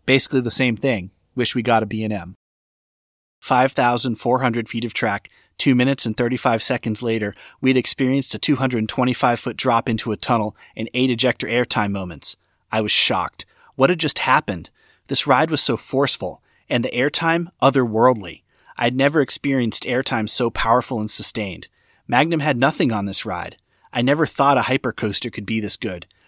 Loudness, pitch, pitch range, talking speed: -19 LUFS, 120 Hz, 110-130 Hz, 185 wpm